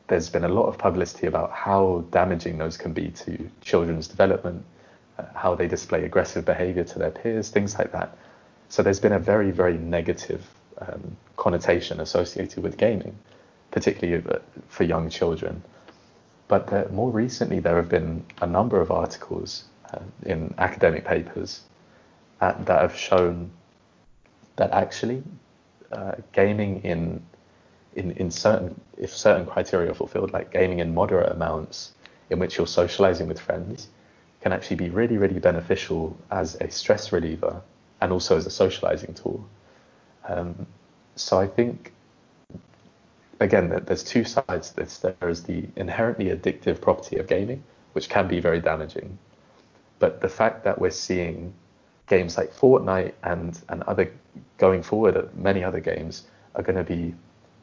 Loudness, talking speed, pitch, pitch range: -24 LUFS, 155 wpm, 90 Hz, 85-100 Hz